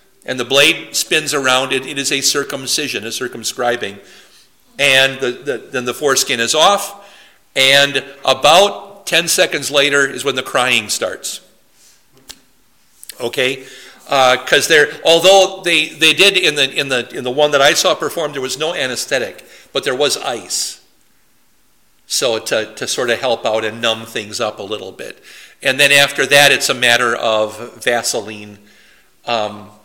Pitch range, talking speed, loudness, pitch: 125-165 Hz, 160 wpm, -14 LUFS, 140 Hz